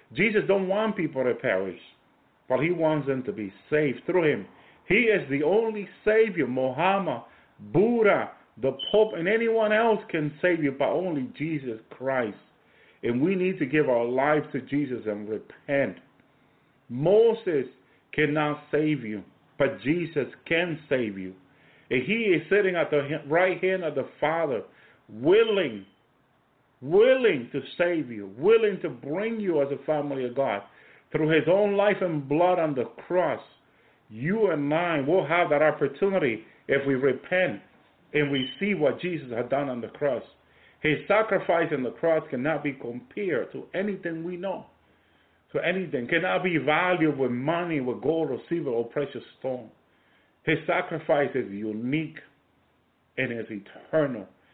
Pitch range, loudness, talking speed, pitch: 135-185 Hz, -26 LUFS, 155 wpm, 155 Hz